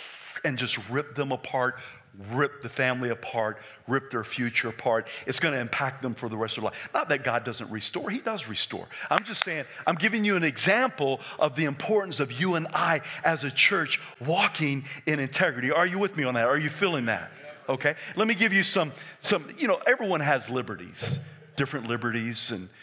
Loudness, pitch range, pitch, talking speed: -27 LUFS, 120-155 Hz, 135 Hz, 205 wpm